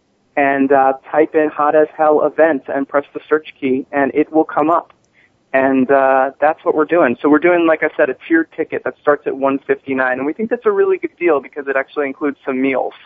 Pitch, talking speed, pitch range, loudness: 145 Hz, 235 wpm, 135-155 Hz, -16 LUFS